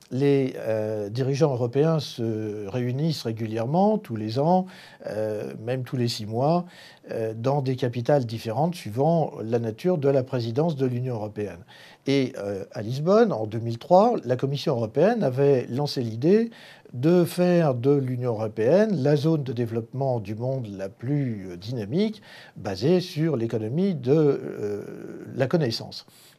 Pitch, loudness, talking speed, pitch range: 130 Hz, -25 LUFS, 145 wpm, 115-155 Hz